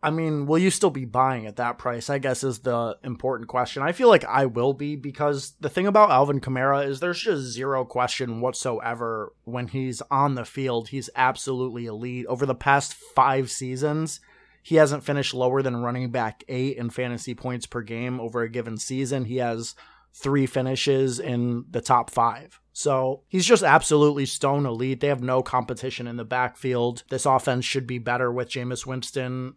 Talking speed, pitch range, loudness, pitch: 190 wpm, 125-140 Hz, -24 LUFS, 130 Hz